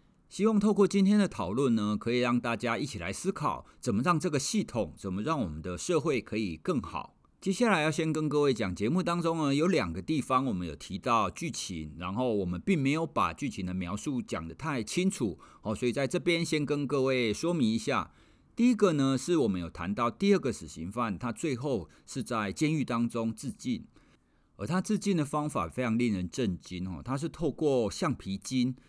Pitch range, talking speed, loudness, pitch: 110-175 Hz, 300 characters per minute, -30 LUFS, 135 Hz